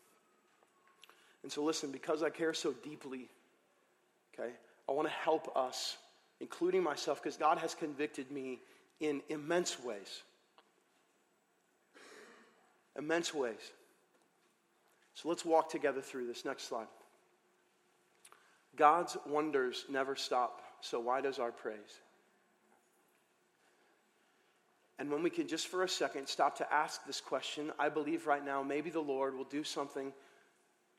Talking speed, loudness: 125 wpm, -37 LUFS